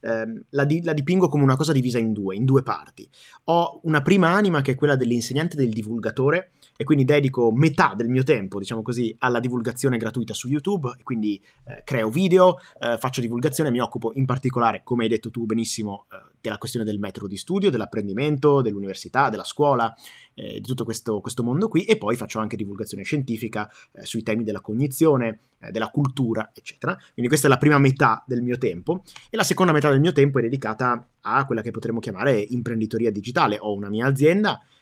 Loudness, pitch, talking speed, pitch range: -22 LUFS, 125 Hz, 200 wpm, 115-145 Hz